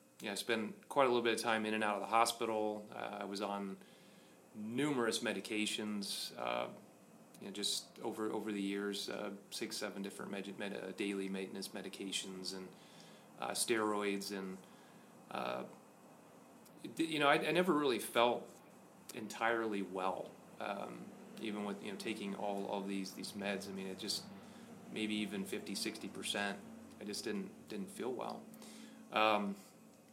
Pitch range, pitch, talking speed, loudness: 100-110 Hz, 105 Hz, 160 wpm, -39 LUFS